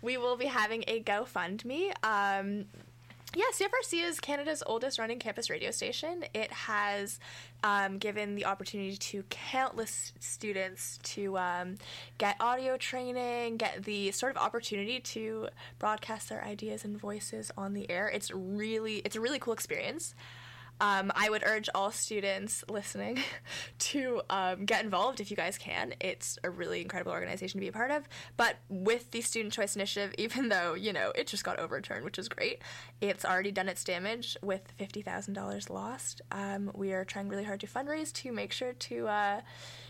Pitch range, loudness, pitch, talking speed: 195-240 Hz, -34 LUFS, 205 Hz, 175 wpm